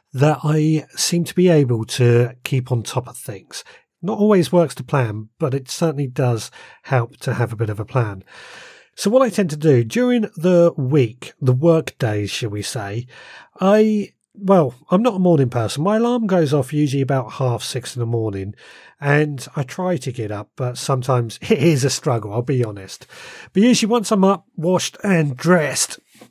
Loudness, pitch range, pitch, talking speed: -19 LUFS, 125-175 Hz, 140 Hz, 195 wpm